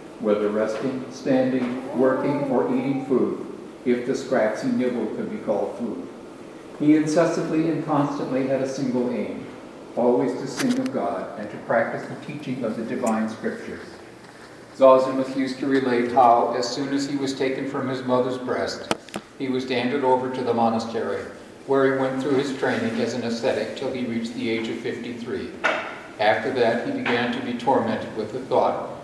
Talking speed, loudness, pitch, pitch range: 180 wpm, -24 LUFS, 130 Hz, 120-135 Hz